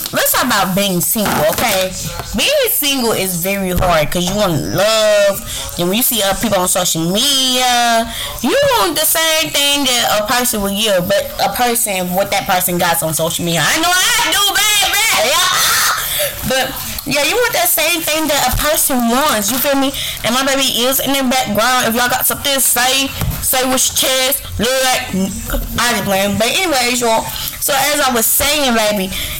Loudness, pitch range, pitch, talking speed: -13 LUFS, 200-285 Hz, 250 Hz, 190 wpm